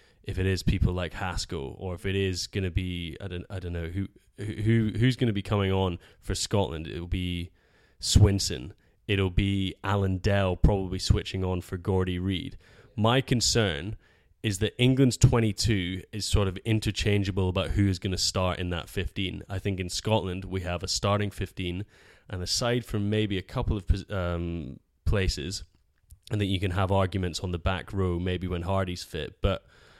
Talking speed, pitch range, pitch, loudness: 180 wpm, 90-105 Hz, 95 Hz, -28 LUFS